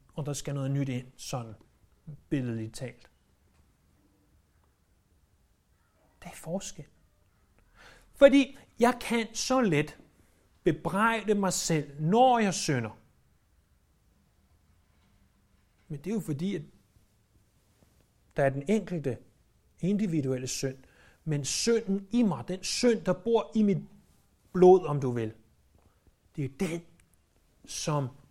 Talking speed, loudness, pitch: 110 wpm, -28 LUFS, 135 Hz